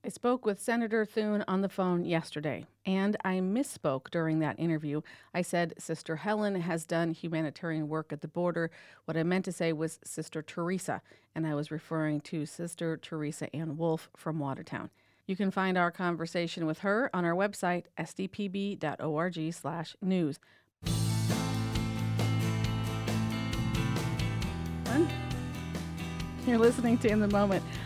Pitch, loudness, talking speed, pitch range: 165 Hz, -32 LUFS, 140 wpm, 150-190 Hz